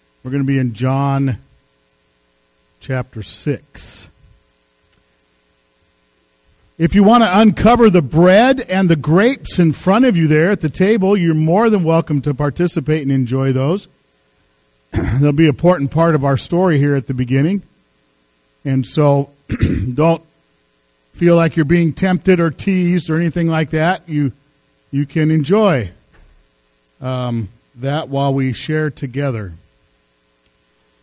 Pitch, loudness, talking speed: 140 Hz, -15 LUFS, 135 wpm